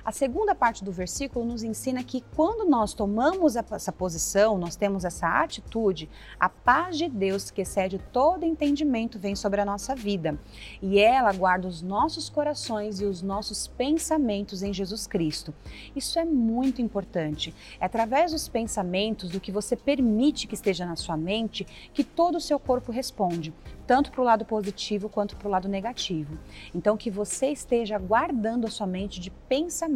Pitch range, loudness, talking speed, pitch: 195-260 Hz, -27 LUFS, 170 wpm, 215 Hz